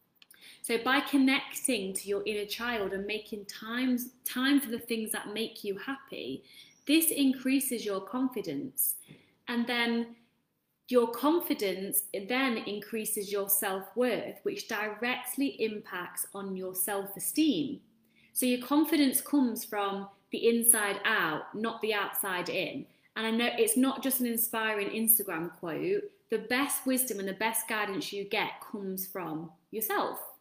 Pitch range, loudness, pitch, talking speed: 200-255 Hz, -30 LUFS, 225 Hz, 140 wpm